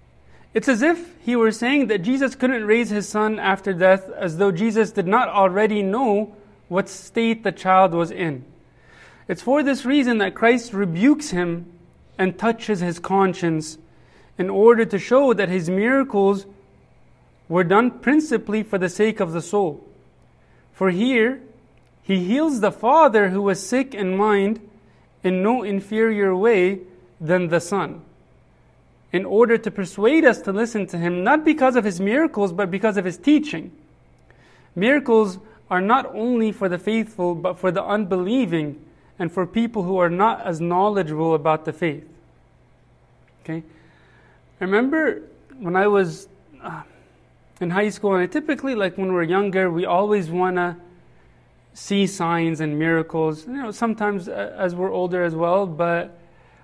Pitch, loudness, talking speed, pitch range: 195 Hz, -20 LUFS, 155 wpm, 175-225 Hz